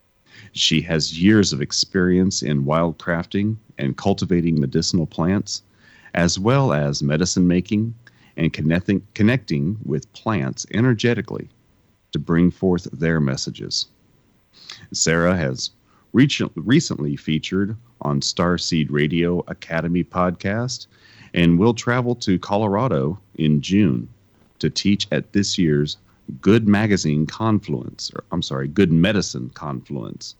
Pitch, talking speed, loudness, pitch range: 90 Hz, 115 wpm, -20 LUFS, 80-105 Hz